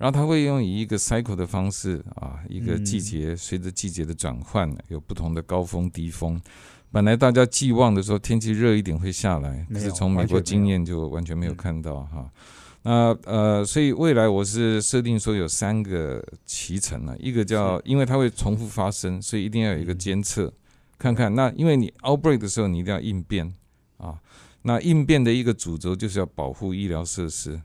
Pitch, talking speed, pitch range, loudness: 100 Hz, 320 characters per minute, 85-115 Hz, -23 LUFS